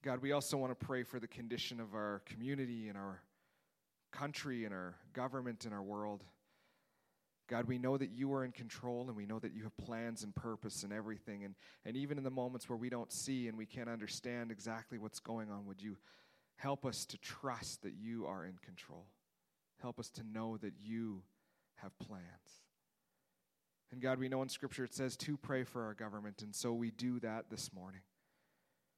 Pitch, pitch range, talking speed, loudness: 115 Hz, 105-130 Hz, 200 wpm, -44 LUFS